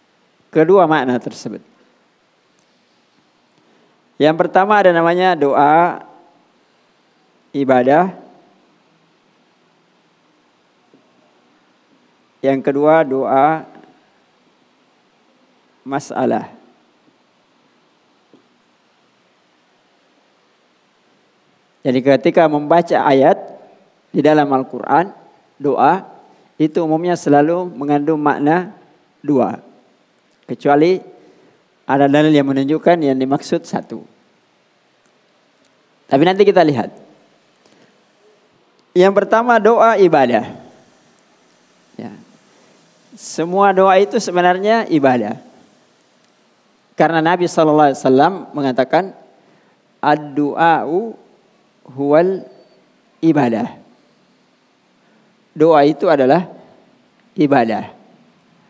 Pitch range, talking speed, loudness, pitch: 135-180 Hz, 60 wpm, -14 LUFS, 155 Hz